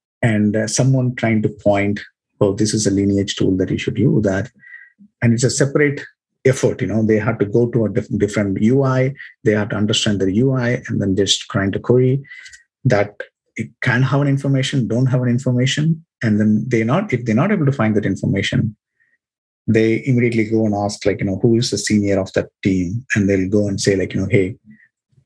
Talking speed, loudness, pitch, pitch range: 215 wpm, -17 LUFS, 115 Hz, 105-130 Hz